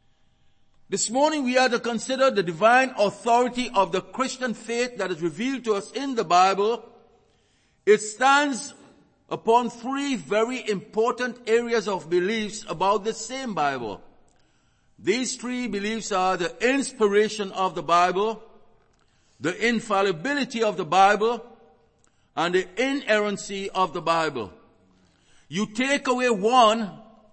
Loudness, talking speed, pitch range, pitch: -23 LUFS, 125 wpm, 195-245 Hz, 220 Hz